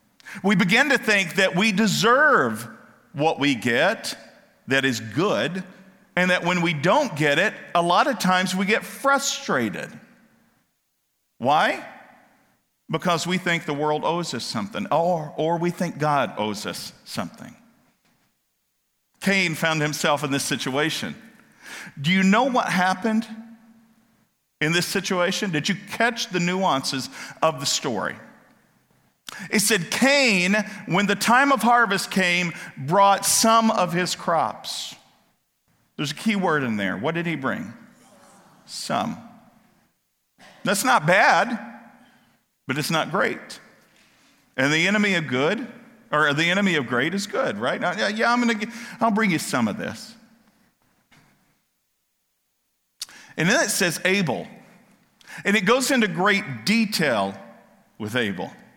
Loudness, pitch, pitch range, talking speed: -22 LUFS, 190 Hz, 160-225 Hz, 135 wpm